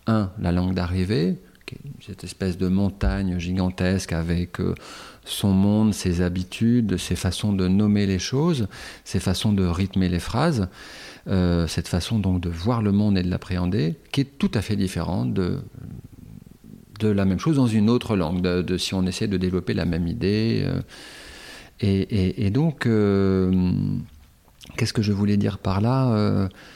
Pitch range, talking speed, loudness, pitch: 90-110 Hz, 170 wpm, -23 LUFS, 95 Hz